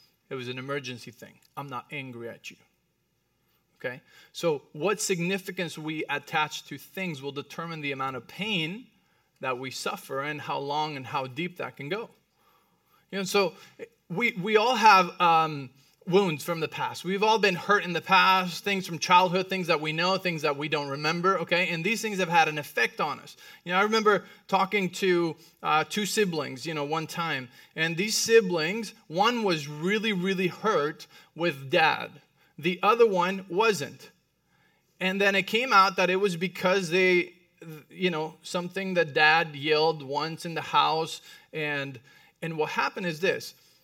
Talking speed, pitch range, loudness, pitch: 180 wpm, 155-195 Hz, -26 LUFS, 175 Hz